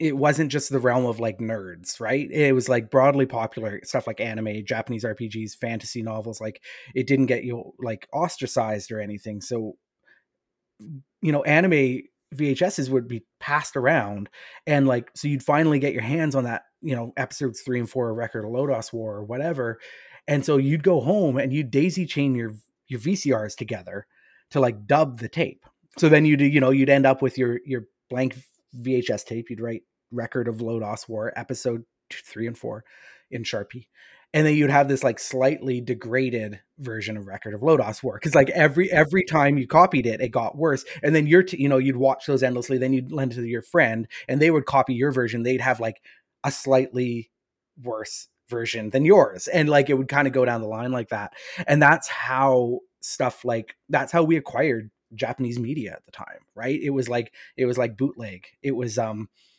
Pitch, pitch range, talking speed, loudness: 130 Hz, 115-140 Hz, 200 wpm, -23 LUFS